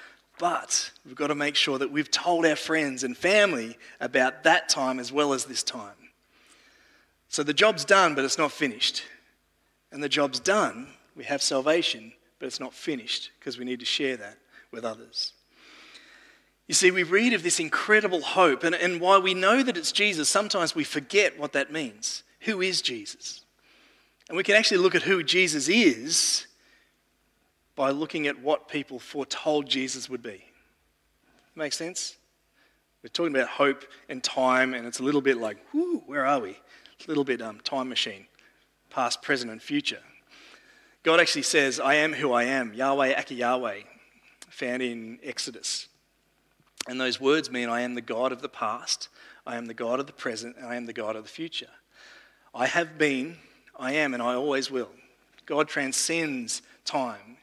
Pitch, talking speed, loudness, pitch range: 145 Hz, 180 wpm, -26 LUFS, 130-175 Hz